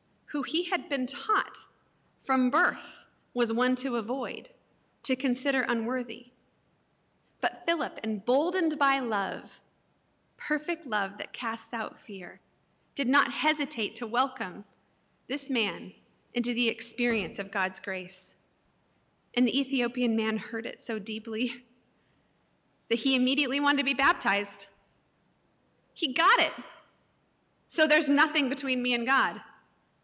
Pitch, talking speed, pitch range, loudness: 250 Hz, 125 wpm, 225-280 Hz, -28 LUFS